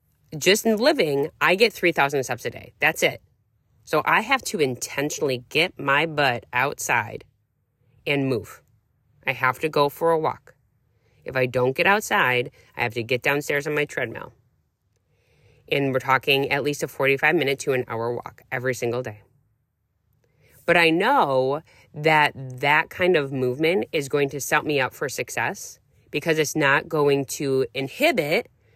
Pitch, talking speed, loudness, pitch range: 135 Hz, 165 wpm, -22 LUFS, 125-150 Hz